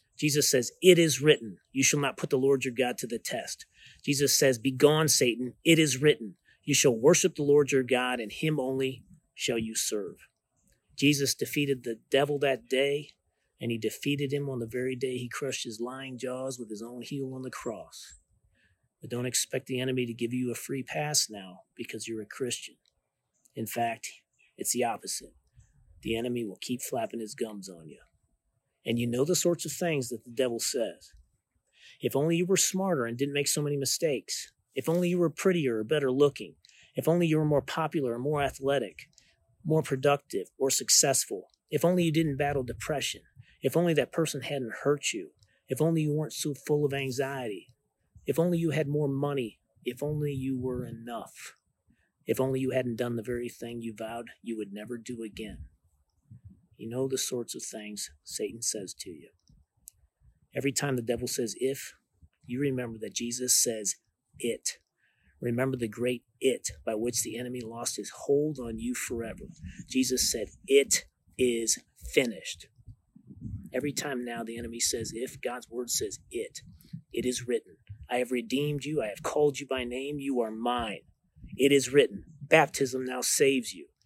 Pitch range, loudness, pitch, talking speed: 120-145 Hz, -29 LUFS, 130 Hz, 185 wpm